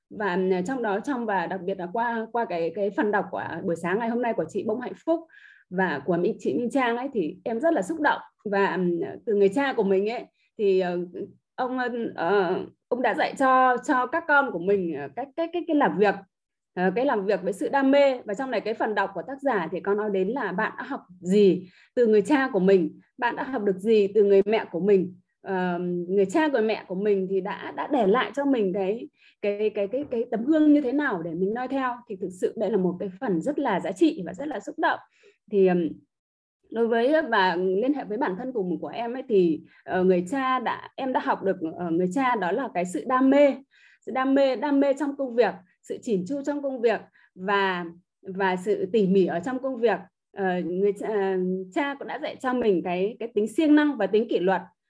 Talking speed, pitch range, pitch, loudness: 240 wpm, 190-260 Hz, 210 Hz, -25 LUFS